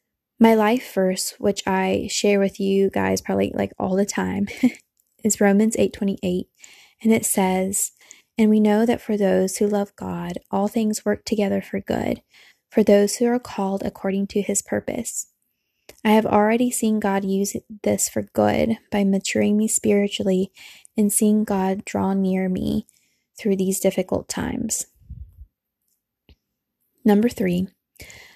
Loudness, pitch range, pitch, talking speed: -21 LUFS, 190-215 Hz, 205 Hz, 145 wpm